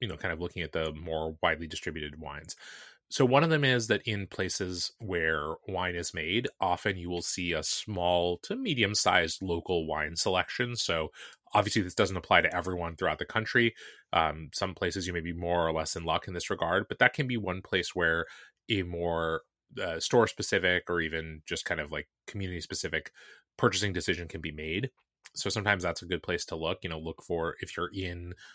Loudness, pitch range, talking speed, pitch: -30 LUFS, 80-100 Hz, 210 wpm, 90 Hz